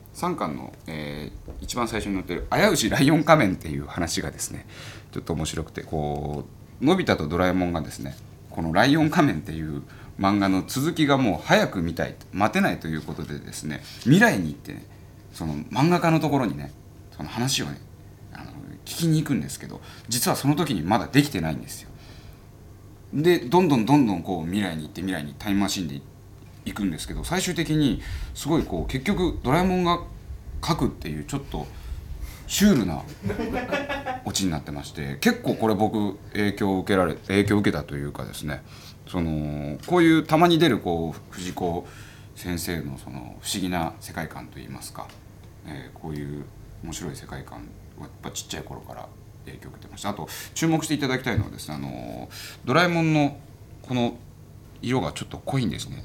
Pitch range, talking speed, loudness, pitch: 80-130 Hz, 380 characters per minute, -24 LUFS, 100 Hz